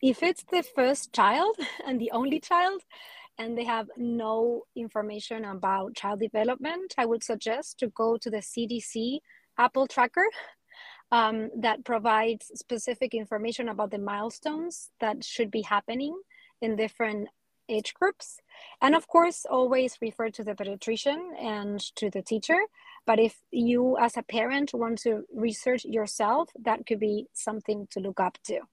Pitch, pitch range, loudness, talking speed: 230 Hz, 220-270 Hz, -28 LUFS, 150 wpm